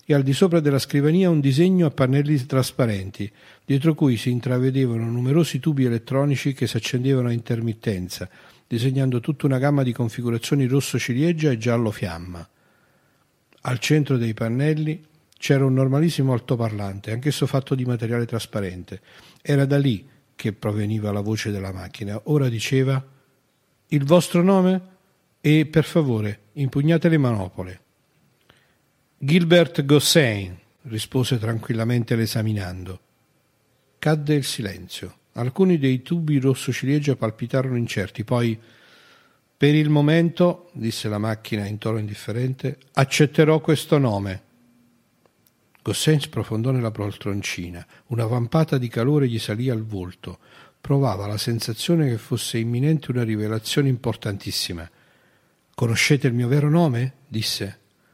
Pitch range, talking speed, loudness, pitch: 110-145 Hz, 125 wpm, -22 LUFS, 130 Hz